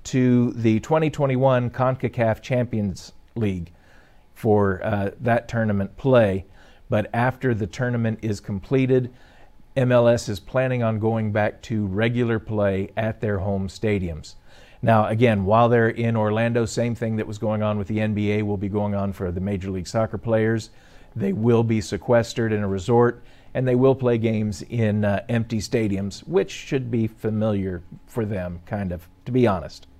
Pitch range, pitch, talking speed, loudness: 100-120 Hz, 110 Hz, 165 wpm, -23 LUFS